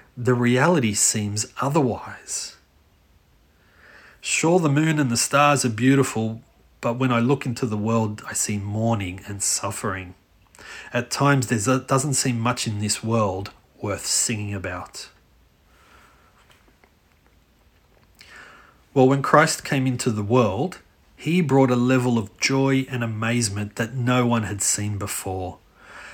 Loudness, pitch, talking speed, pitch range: -22 LUFS, 115 Hz, 130 wpm, 100-130 Hz